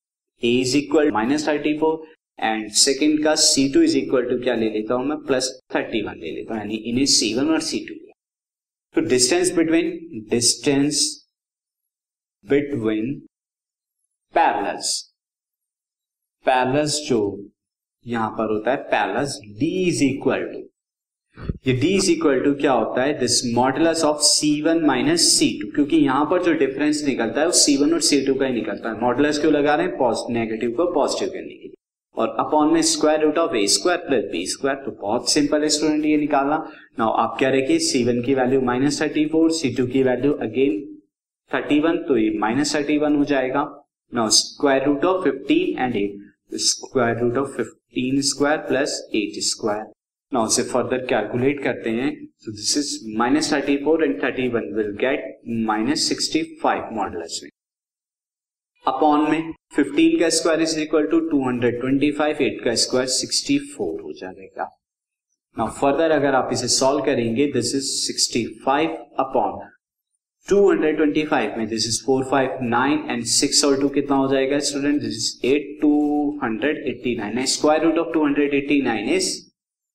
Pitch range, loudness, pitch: 125-160 Hz, -20 LUFS, 145 Hz